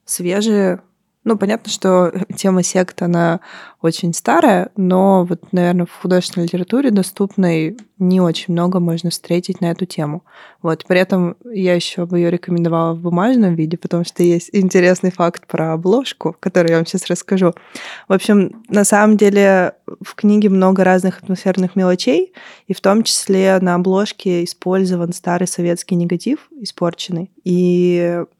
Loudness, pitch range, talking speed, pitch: -16 LUFS, 175-195 Hz, 150 wpm, 185 Hz